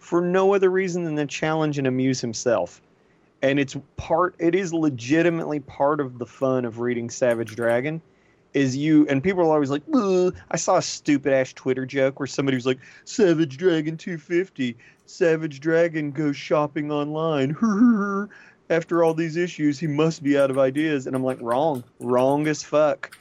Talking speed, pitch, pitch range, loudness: 180 wpm, 150 Hz, 135-165 Hz, -23 LUFS